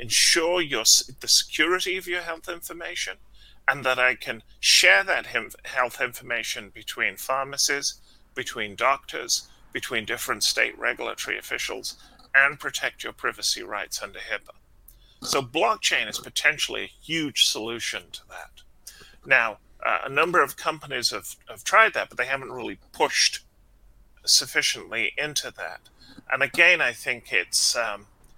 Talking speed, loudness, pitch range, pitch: 140 wpm, -23 LUFS, 120-165 Hz, 135 Hz